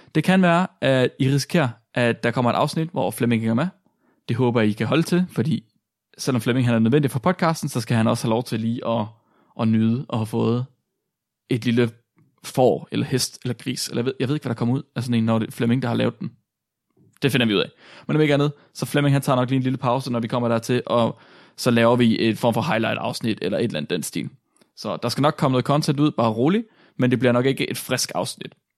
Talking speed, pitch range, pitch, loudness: 265 wpm, 115-145 Hz, 125 Hz, -22 LUFS